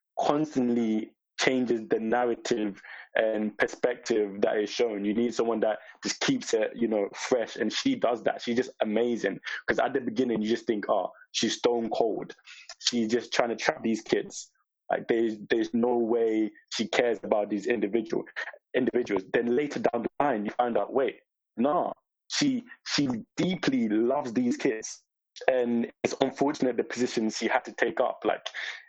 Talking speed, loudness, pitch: 170 wpm, -28 LUFS, 120 Hz